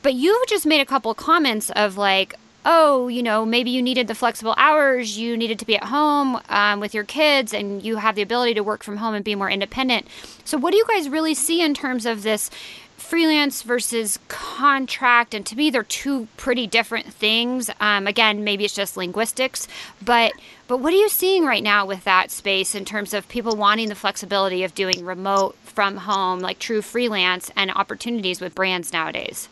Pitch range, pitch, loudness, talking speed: 205-265 Hz, 225 Hz, -20 LUFS, 205 wpm